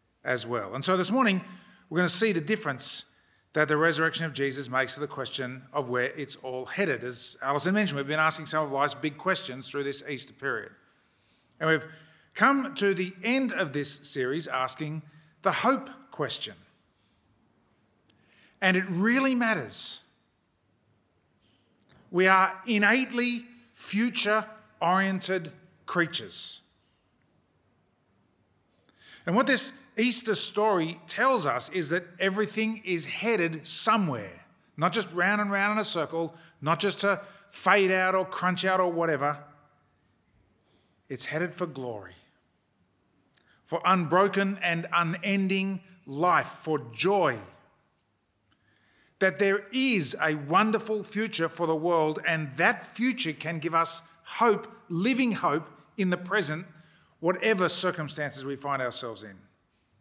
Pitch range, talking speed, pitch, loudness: 145-200 Hz, 135 wpm, 170 Hz, -27 LUFS